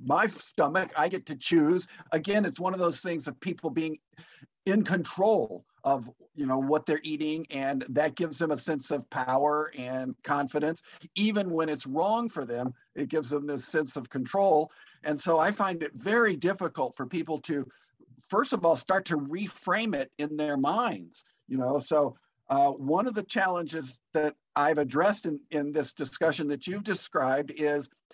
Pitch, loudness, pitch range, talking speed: 155 Hz, -29 LUFS, 145-175 Hz, 180 wpm